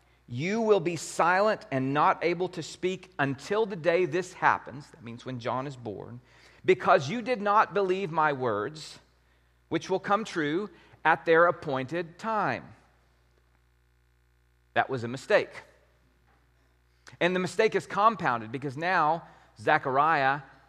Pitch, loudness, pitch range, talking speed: 150 Hz, -27 LUFS, 110-185 Hz, 135 wpm